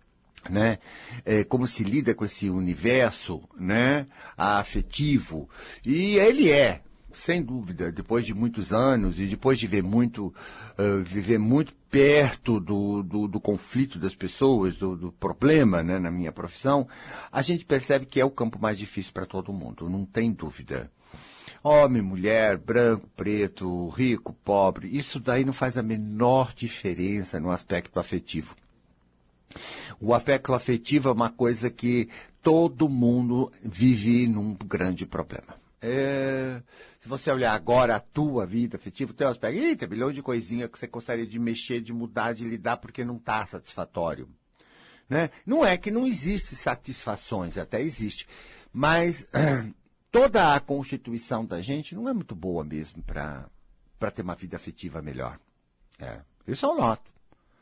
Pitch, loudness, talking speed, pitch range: 115 Hz, -26 LUFS, 150 wpm, 95-130 Hz